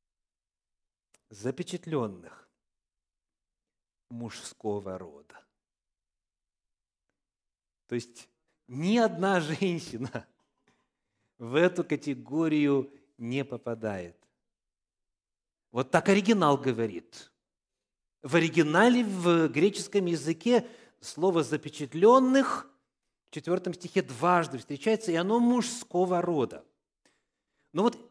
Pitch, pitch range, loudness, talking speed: 160 Hz, 120-185 Hz, -28 LUFS, 75 wpm